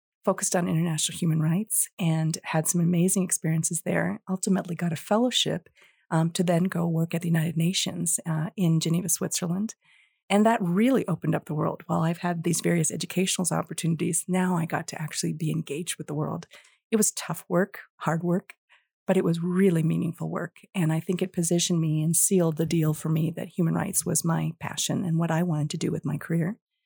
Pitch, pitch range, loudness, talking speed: 170 Hz, 160-185 Hz, -26 LUFS, 205 wpm